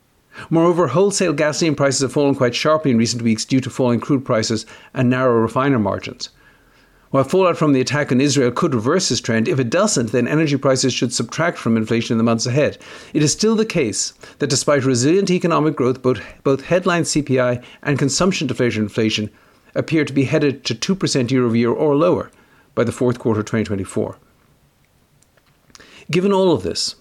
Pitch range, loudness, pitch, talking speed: 120-155 Hz, -18 LUFS, 135 Hz, 185 wpm